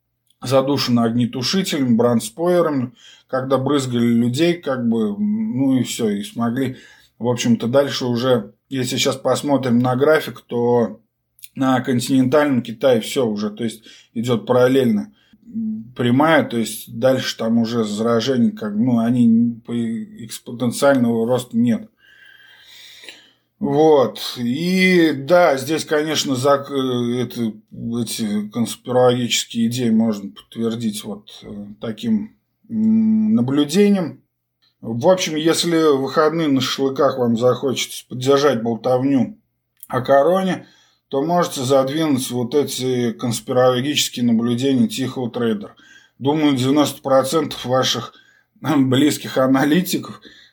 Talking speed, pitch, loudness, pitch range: 100 wpm, 130 Hz, -18 LUFS, 120-155 Hz